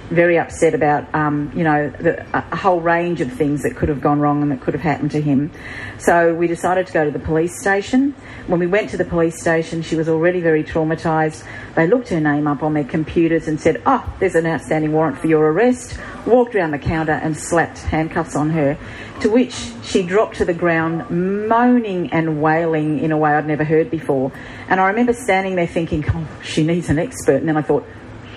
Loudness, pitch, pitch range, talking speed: -18 LUFS, 160 Hz, 150-175 Hz, 220 wpm